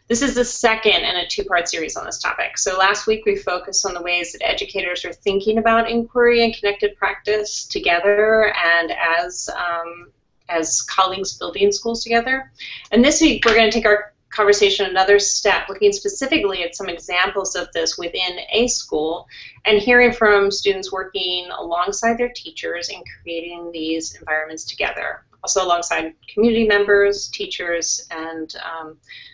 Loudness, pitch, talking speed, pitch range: -18 LUFS, 200 Hz, 160 wpm, 175-225 Hz